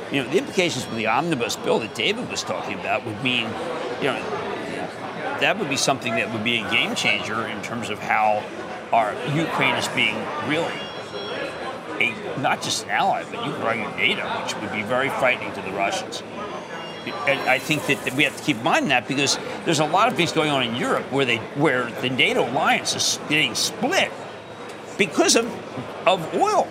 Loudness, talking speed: -22 LUFS, 195 wpm